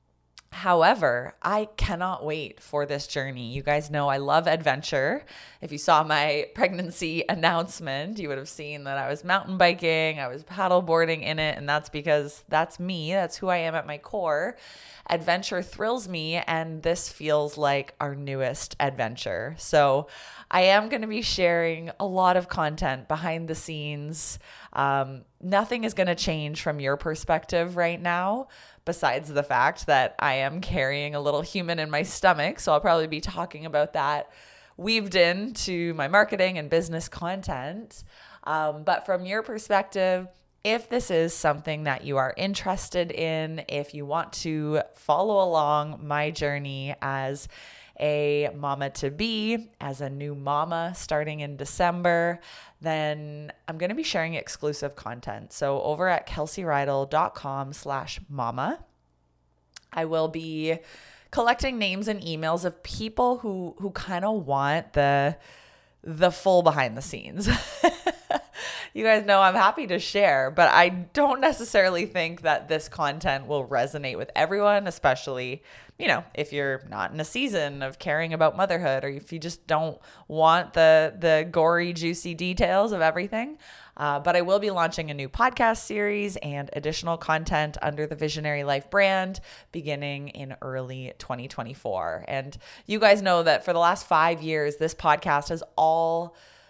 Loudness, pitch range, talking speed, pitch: -25 LUFS, 145-180 Hz, 160 wpm, 160 Hz